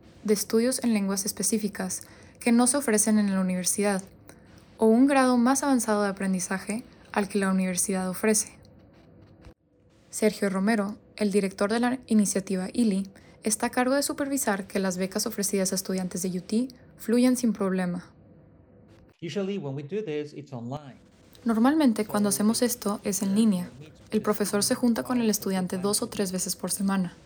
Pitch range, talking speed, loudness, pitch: 190-225 Hz, 150 wpm, -26 LUFS, 205 Hz